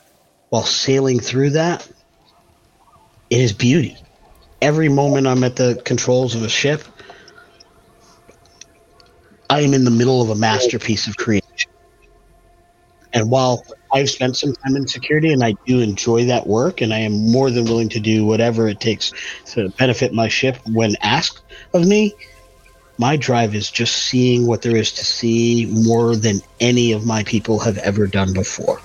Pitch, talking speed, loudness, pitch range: 120 Hz, 165 wpm, -17 LUFS, 110-130 Hz